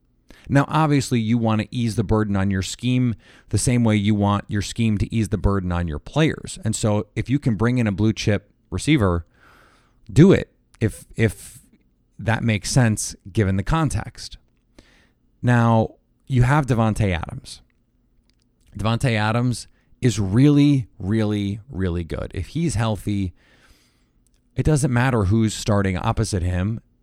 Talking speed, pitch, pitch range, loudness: 150 wpm, 110 Hz, 100-120 Hz, -21 LUFS